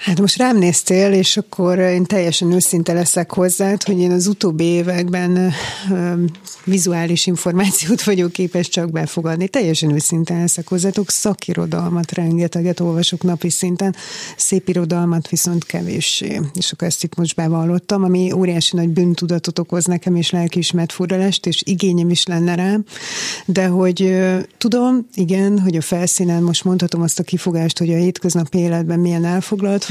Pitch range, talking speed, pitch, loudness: 170-185 Hz, 150 wpm, 180 Hz, -16 LUFS